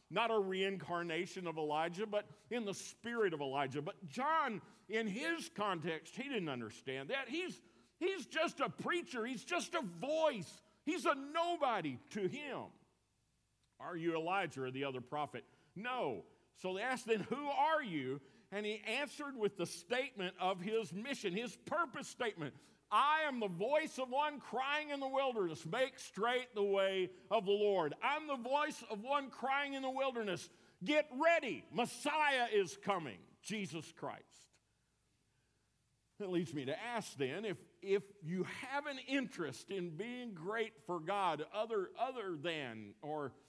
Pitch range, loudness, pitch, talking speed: 175-270 Hz, -39 LUFS, 210 Hz, 160 wpm